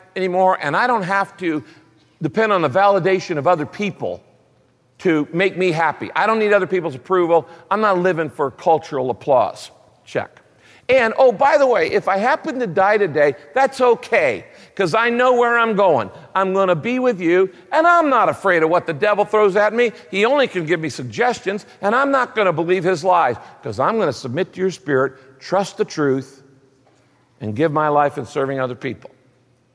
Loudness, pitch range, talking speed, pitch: -18 LUFS, 145-210 Hz, 200 wpm, 185 Hz